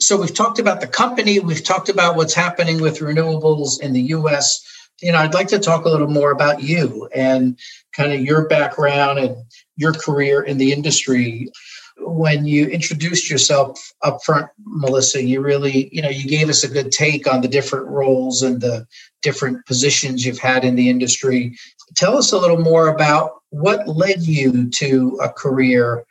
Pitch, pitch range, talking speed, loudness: 145 Hz, 130-160 Hz, 185 wpm, -16 LUFS